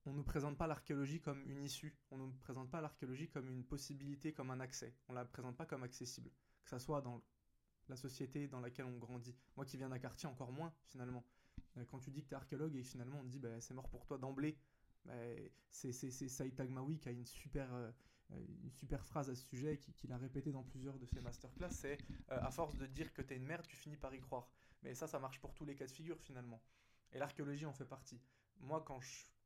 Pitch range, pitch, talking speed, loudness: 125-145 Hz, 135 Hz, 255 wpm, -50 LUFS